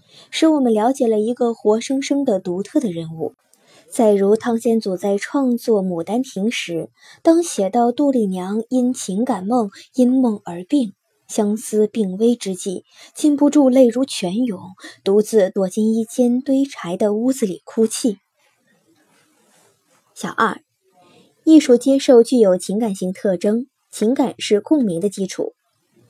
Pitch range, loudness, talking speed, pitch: 200-255 Hz, -18 LUFS, 210 characters per minute, 230 Hz